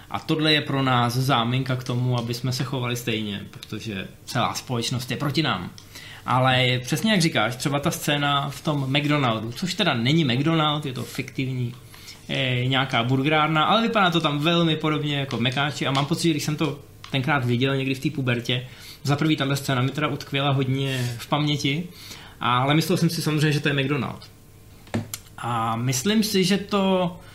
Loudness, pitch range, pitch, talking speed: -23 LUFS, 120-155 Hz, 135 Hz, 185 wpm